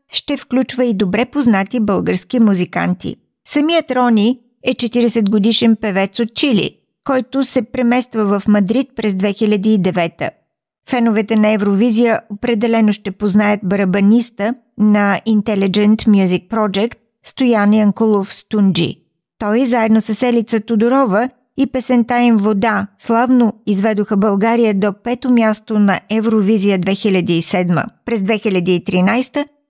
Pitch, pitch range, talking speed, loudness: 220 Hz, 205-240 Hz, 115 wpm, -15 LUFS